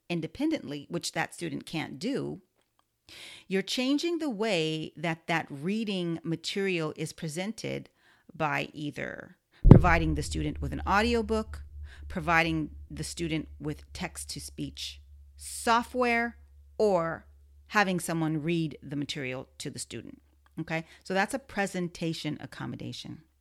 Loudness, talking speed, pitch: -30 LUFS, 120 wpm, 160 Hz